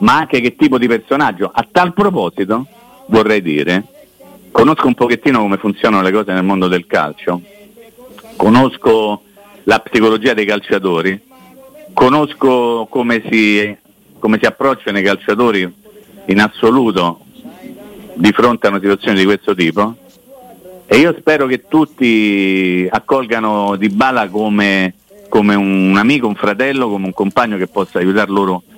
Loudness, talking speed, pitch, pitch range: -13 LUFS, 135 wpm, 110 Hz, 100-155 Hz